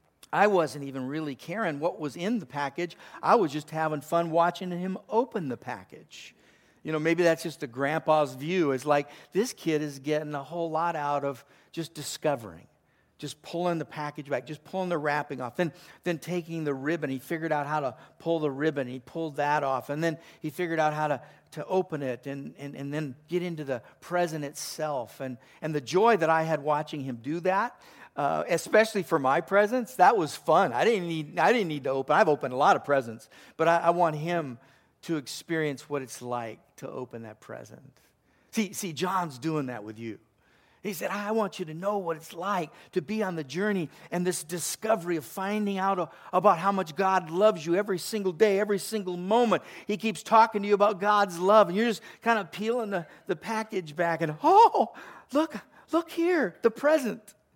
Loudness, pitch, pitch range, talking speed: -28 LUFS, 165 Hz, 150-195 Hz, 215 wpm